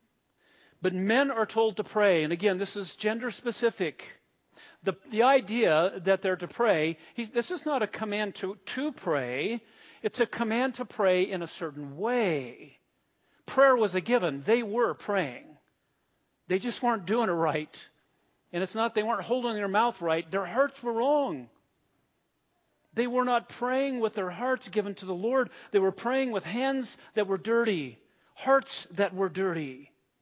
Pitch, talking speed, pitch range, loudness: 215 Hz, 170 wpm, 190-240 Hz, -29 LUFS